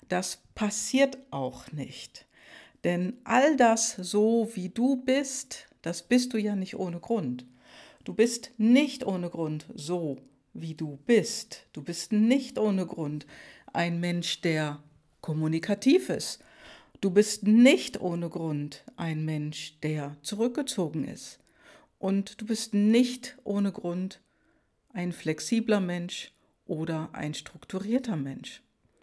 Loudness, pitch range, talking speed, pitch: -28 LUFS, 160-230 Hz, 125 wpm, 185 Hz